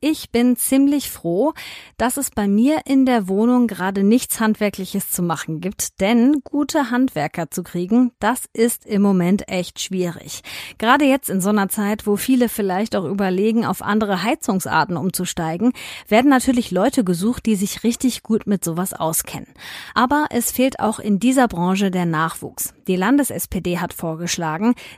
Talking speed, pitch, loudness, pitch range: 160 wpm, 210 Hz, -19 LUFS, 185-245 Hz